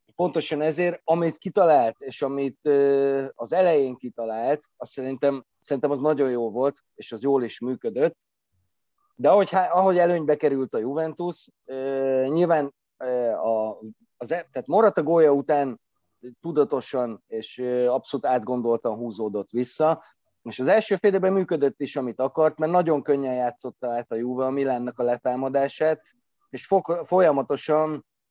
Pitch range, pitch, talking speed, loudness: 125-160 Hz, 140 Hz, 130 wpm, -24 LUFS